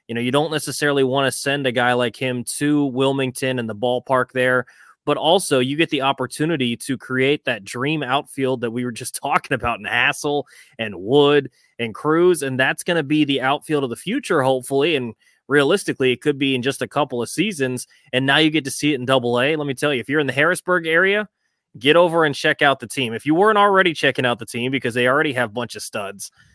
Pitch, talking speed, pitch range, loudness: 135 Hz, 240 wpm, 125-150 Hz, -19 LUFS